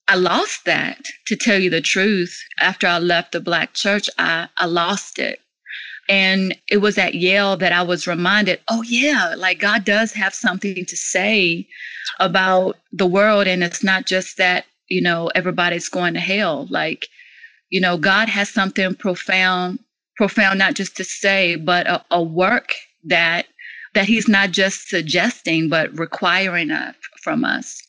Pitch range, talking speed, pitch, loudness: 180-205 Hz, 165 wpm, 190 Hz, -17 LUFS